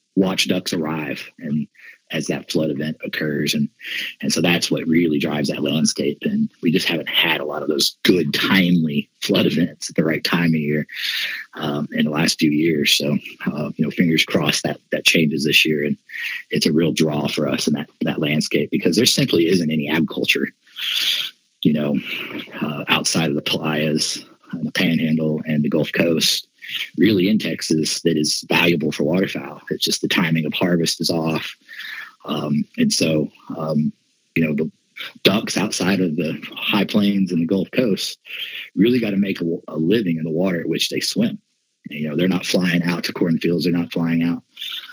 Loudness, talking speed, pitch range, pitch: -20 LUFS, 195 wpm, 75-90 Hz, 80 Hz